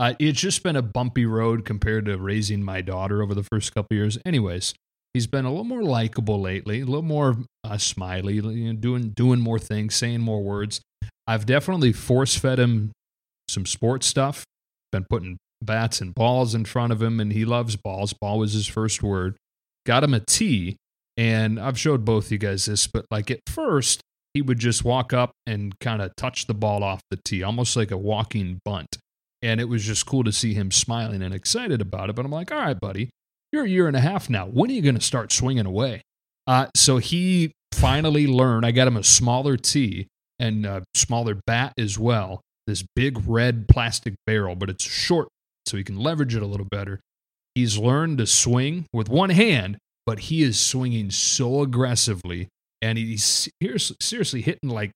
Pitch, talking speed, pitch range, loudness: 115 Hz, 200 wpm, 105-130 Hz, -22 LUFS